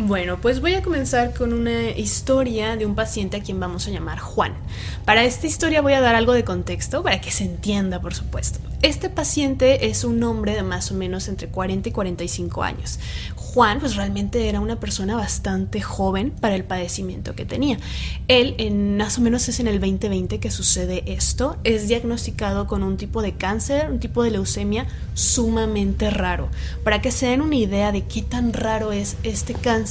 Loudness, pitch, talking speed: -21 LUFS, 200 Hz, 195 wpm